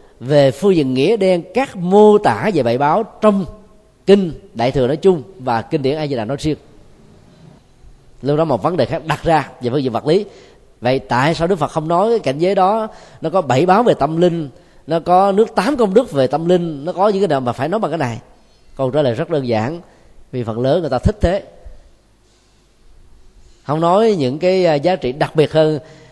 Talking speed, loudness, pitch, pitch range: 225 wpm, -16 LUFS, 155 Hz, 130-185 Hz